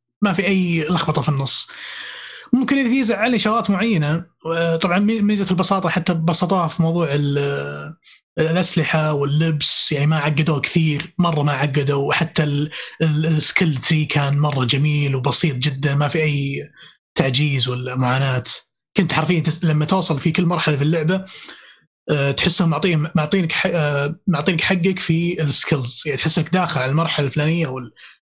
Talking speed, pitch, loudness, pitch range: 135 wpm, 160 Hz, -19 LUFS, 145-180 Hz